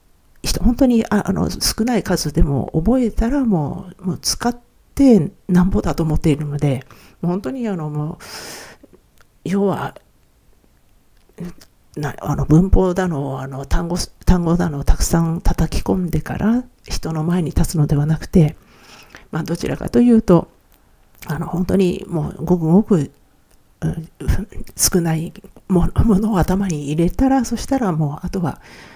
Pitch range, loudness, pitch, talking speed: 150-195 Hz, -18 LUFS, 170 Hz, 265 characters per minute